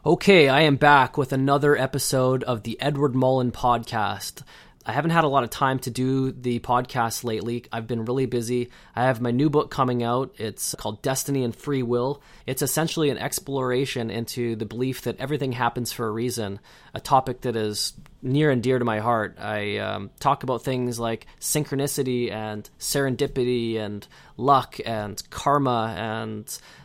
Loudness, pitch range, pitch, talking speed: -24 LUFS, 115-140 Hz, 125 Hz, 175 wpm